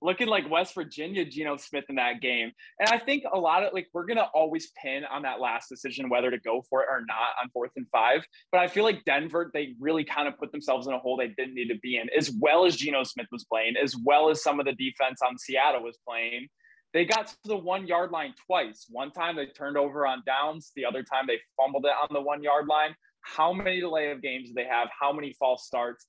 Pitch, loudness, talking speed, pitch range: 140 Hz, -28 LUFS, 260 wpm, 130-160 Hz